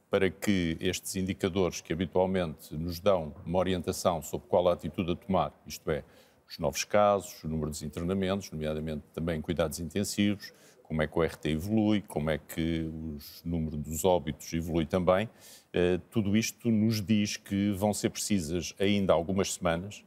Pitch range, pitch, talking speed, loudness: 80-100 Hz, 90 Hz, 165 wpm, -30 LUFS